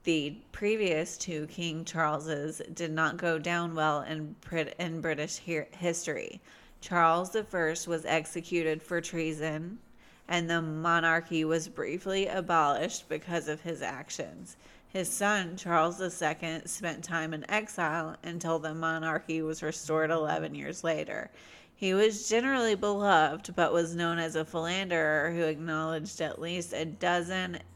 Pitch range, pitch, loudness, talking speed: 160-175 Hz, 165 Hz, -31 LUFS, 140 wpm